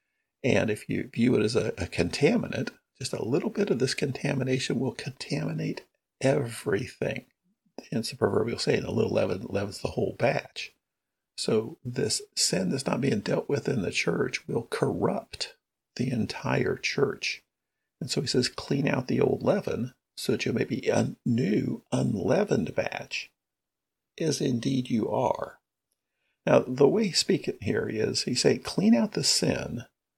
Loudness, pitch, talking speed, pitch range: -28 LUFS, 145 Hz, 165 wpm, 130-215 Hz